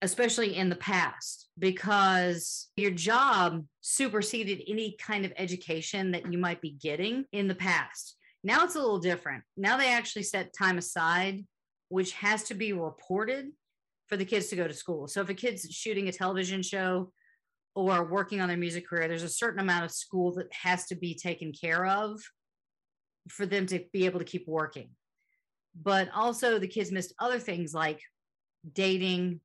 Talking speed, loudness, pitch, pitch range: 175 wpm, -30 LUFS, 190 Hz, 175-205 Hz